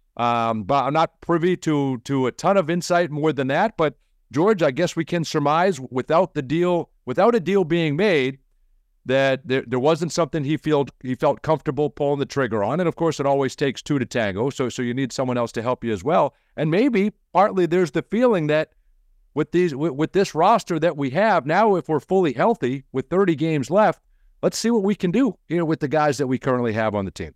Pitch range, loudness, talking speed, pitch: 130-175 Hz, -21 LUFS, 230 wpm, 155 Hz